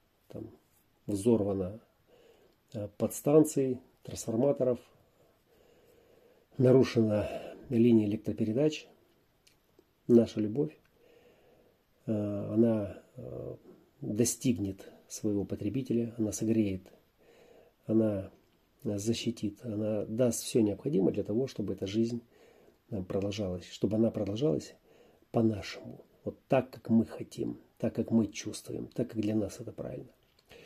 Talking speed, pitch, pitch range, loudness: 90 wpm, 115 Hz, 105-125 Hz, -31 LUFS